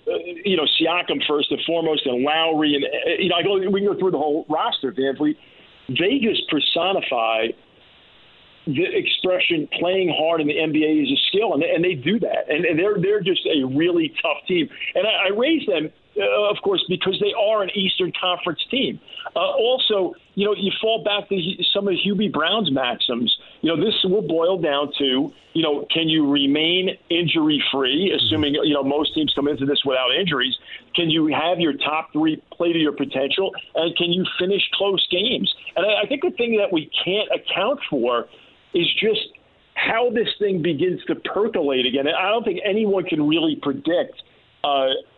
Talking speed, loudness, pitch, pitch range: 195 wpm, -20 LUFS, 185 Hz, 155-225 Hz